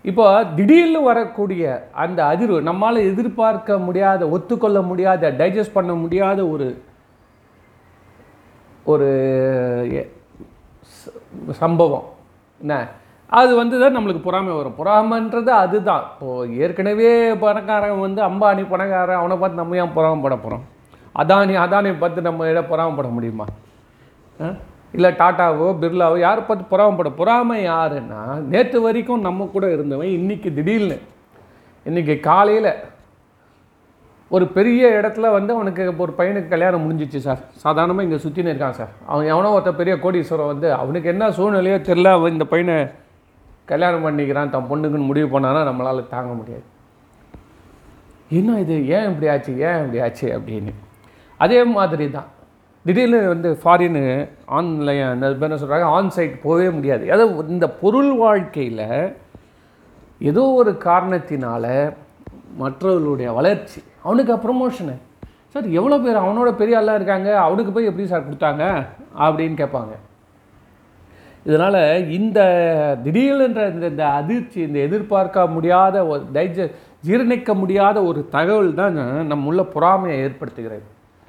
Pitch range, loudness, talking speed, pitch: 140-200 Hz, -17 LUFS, 120 wpm, 175 Hz